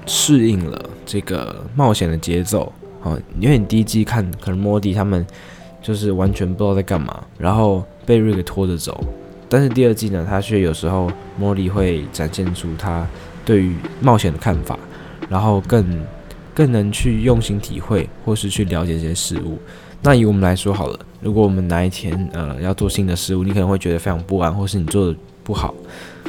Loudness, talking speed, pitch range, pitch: -18 LUFS, 285 characters per minute, 90-105 Hz, 95 Hz